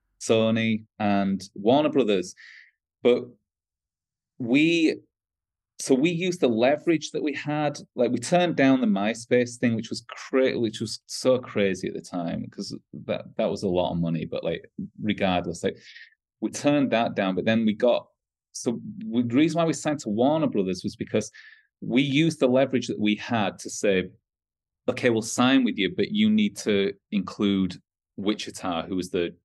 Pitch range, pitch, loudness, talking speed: 105-155 Hz, 120 Hz, -25 LUFS, 170 wpm